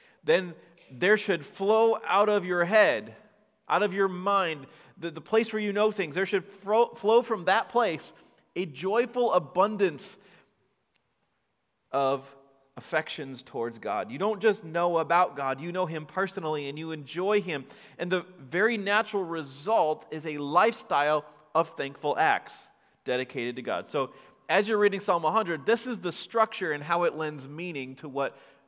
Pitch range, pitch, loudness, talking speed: 150-205 Hz, 175 Hz, -28 LUFS, 165 wpm